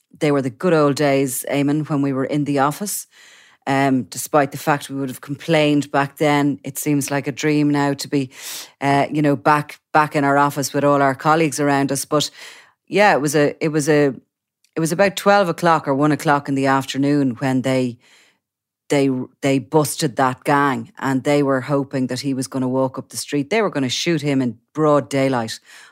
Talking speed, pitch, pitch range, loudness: 215 wpm, 140 Hz, 135-150 Hz, -19 LUFS